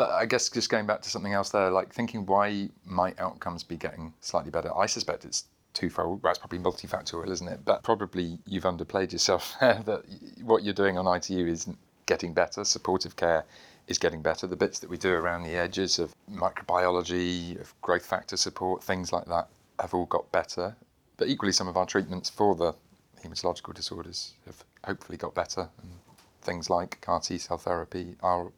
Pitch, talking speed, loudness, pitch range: 90 Hz, 190 wpm, -29 LUFS, 85-100 Hz